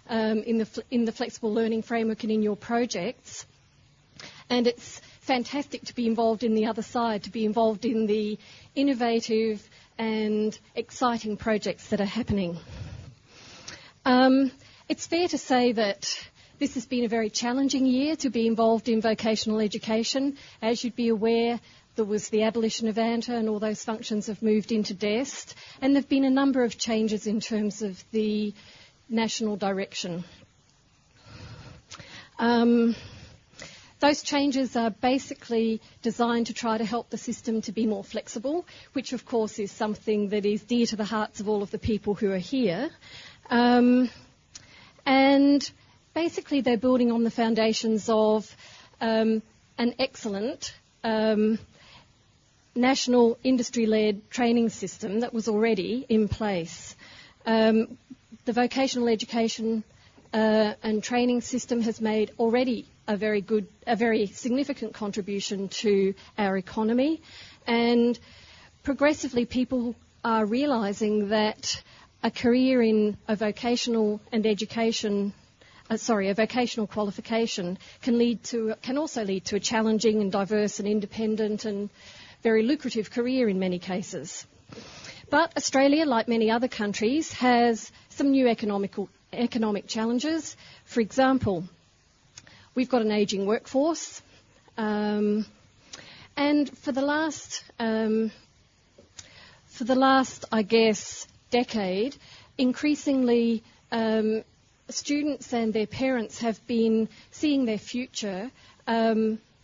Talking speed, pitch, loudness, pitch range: 135 wpm, 225 Hz, -26 LUFS, 215-245 Hz